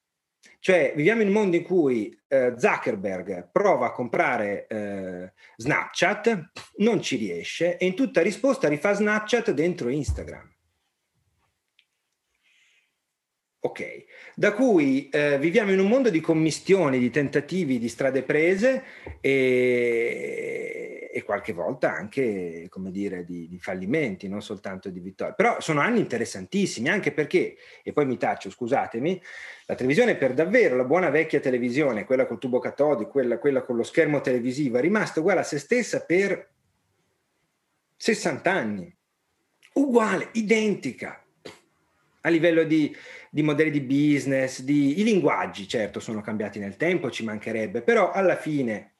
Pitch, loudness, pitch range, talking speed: 160 Hz, -24 LUFS, 130-215 Hz, 140 wpm